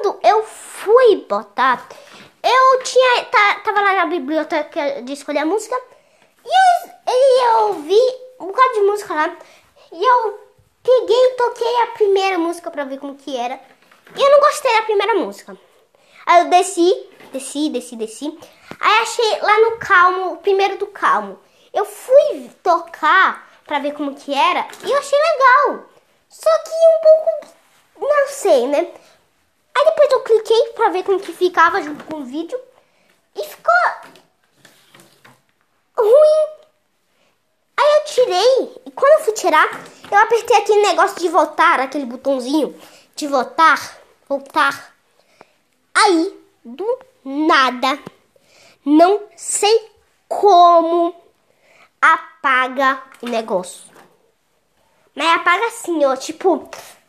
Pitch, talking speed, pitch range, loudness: 350 Hz, 130 wpm, 300-435 Hz, -16 LUFS